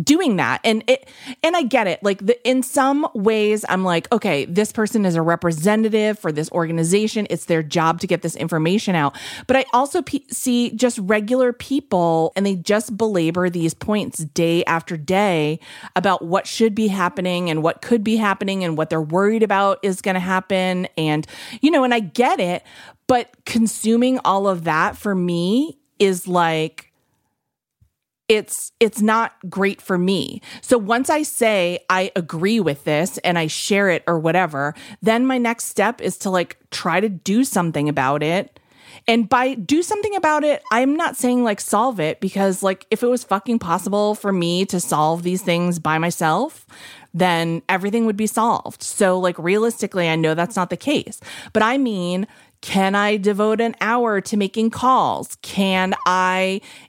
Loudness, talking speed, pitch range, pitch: -19 LUFS, 180 wpm, 175-230 Hz, 200 Hz